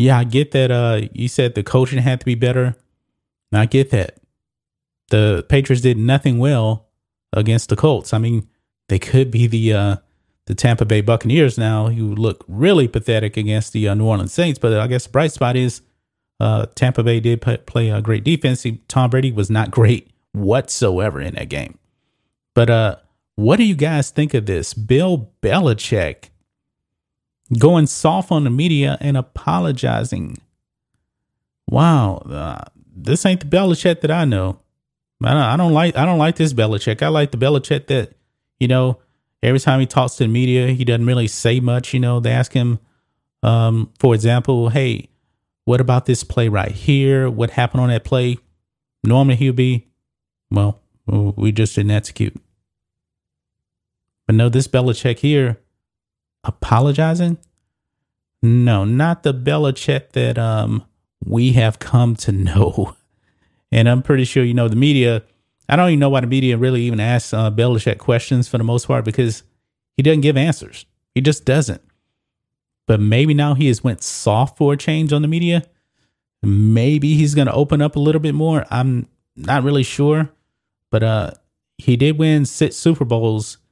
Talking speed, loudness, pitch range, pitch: 170 wpm, -17 LUFS, 110-140 Hz, 125 Hz